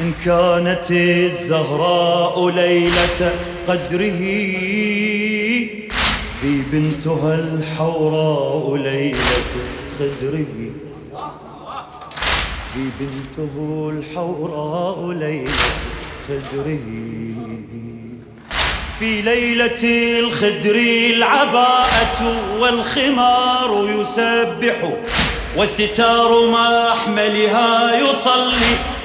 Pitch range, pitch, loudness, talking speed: 150-230 Hz, 175 Hz, -16 LUFS, 50 wpm